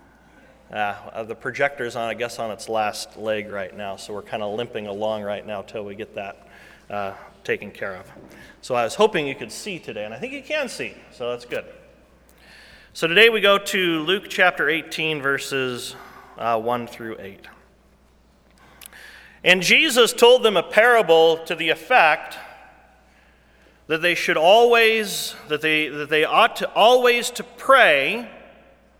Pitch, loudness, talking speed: 155 Hz, -19 LUFS, 165 wpm